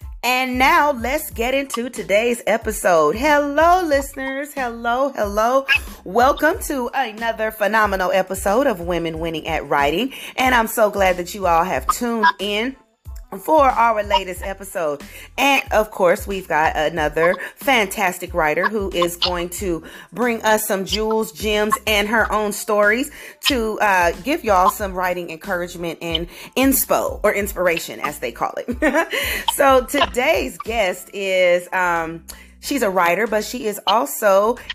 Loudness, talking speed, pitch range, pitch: -19 LUFS, 145 wpm, 180-255 Hz, 215 Hz